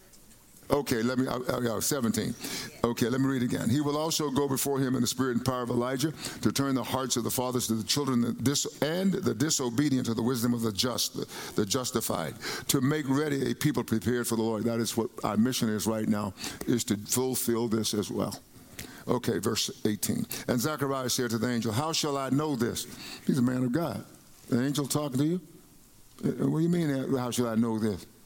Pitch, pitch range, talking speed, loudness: 125 Hz, 115-140 Hz, 225 wpm, -29 LUFS